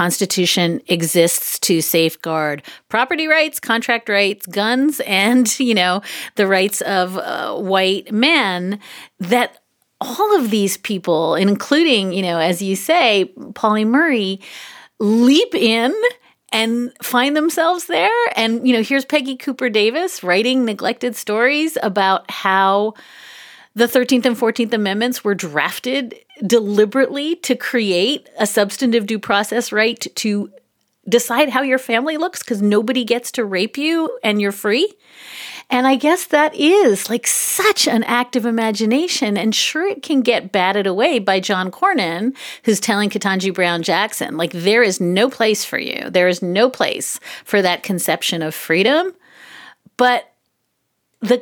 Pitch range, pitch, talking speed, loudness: 195-260 Hz, 230 Hz, 145 wpm, -17 LUFS